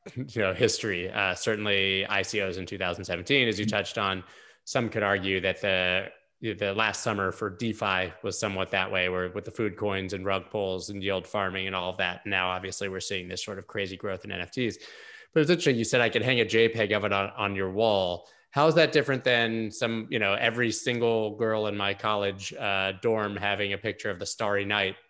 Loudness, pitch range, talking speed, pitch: -27 LUFS, 95-110 Hz, 220 wpm, 100 Hz